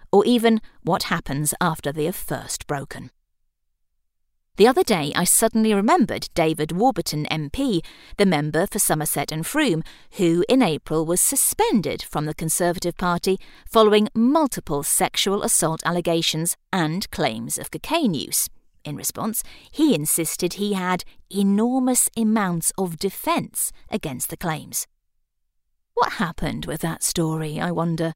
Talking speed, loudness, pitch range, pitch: 135 wpm, -21 LUFS, 160-215 Hz, 175 Hz